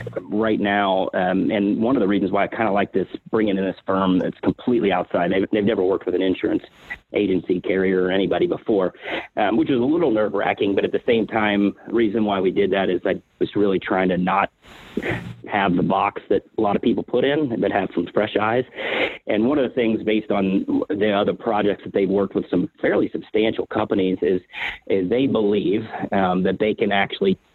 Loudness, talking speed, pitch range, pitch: -21 LUFS, 205 wpm, 95-105 Hz, 100 Hz